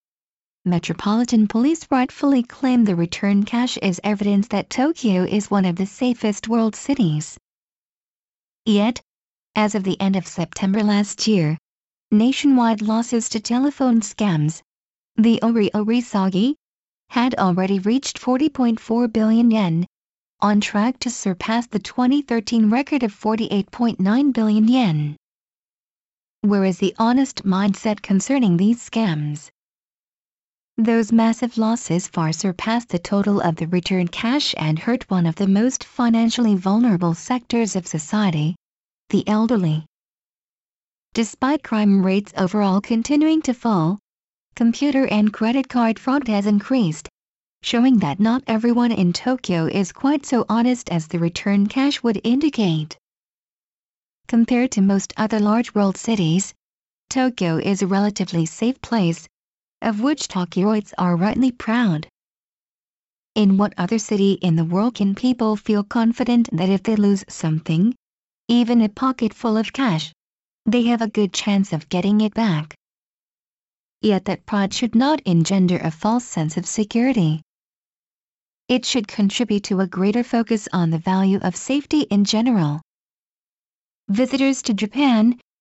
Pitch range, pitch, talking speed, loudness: 190-240 Hz, 215 Hz, 135 wpm, -20 LUFS